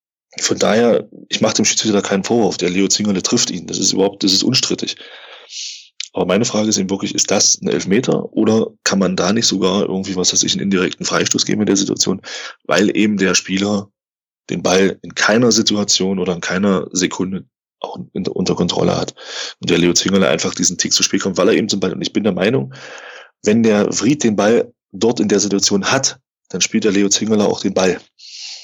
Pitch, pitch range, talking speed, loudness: 100 Hz, 95-105 Hz, 215 wpm, -15 LUFS